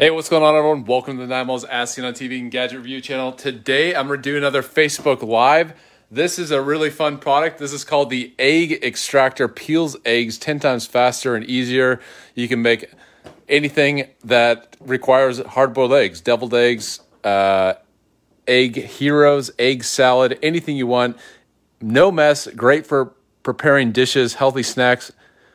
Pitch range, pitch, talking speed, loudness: 125-145 Hz, 130 Hz, 160 wpm, -18 LUFS